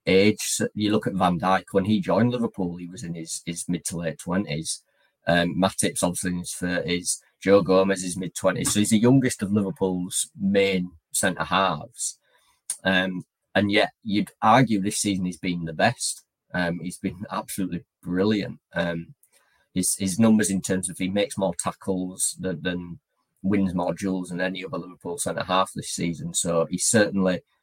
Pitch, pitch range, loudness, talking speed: 95 Hz, 90-100 Hz, -24 LUFS, 180 wpm